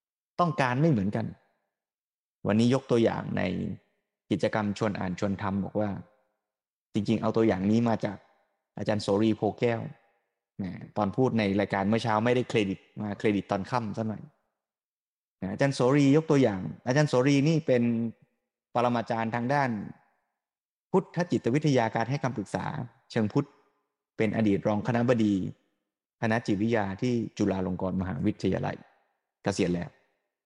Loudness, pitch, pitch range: -28 LUFS, 110 Hz, 100-125 Hz